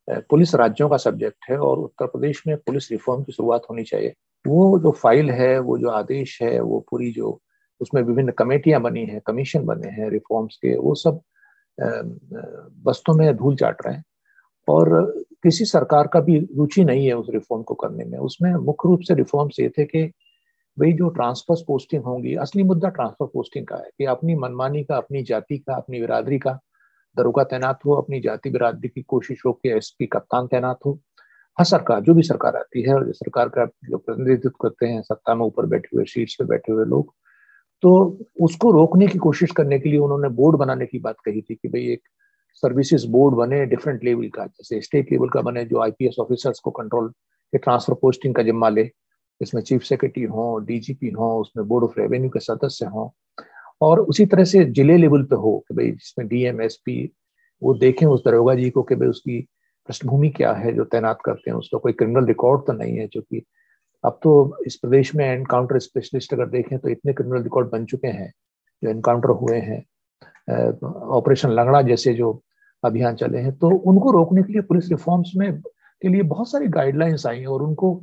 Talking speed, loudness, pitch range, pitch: 200 wpm, -20 LUFS, 120-165 Hz, 135 Hz